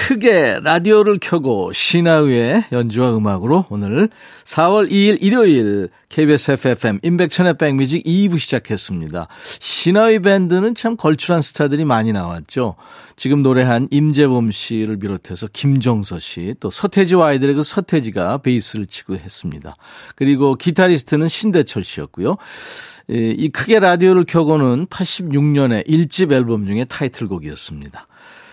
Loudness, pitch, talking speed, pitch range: -15 LUFS, 140 Hz, 315 characters per minute, 115-175 Hz